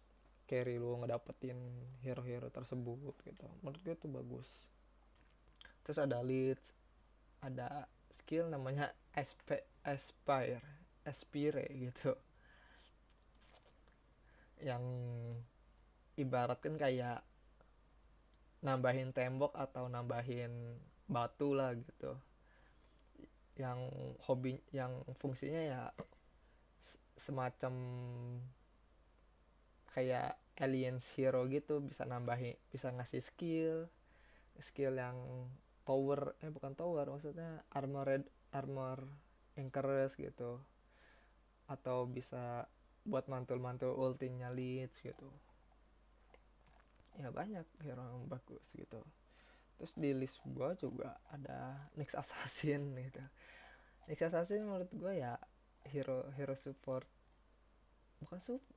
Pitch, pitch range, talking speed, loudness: 130 Hz, 125-140 Hz, 90 wpm, -43 LUFS